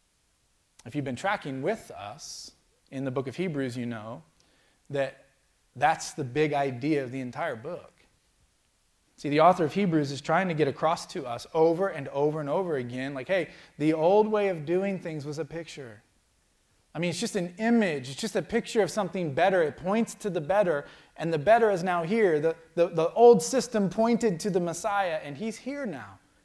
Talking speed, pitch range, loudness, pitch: 200 wpm, 135-195 Hz, -27 LUFS, 160 Hz